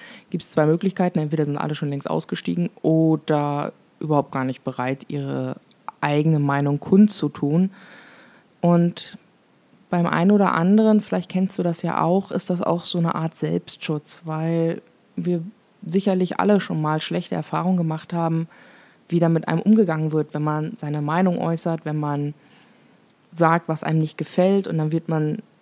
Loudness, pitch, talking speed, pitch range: -22 LUFS, 165 Hz, 160 wpm, 150-185 Hz